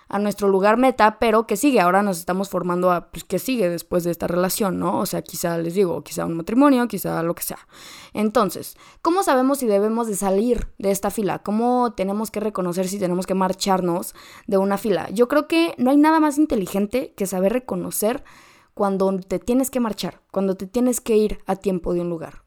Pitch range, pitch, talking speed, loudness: 185-240 Hz, 200 Hz, 210 wpm, -21 LUFS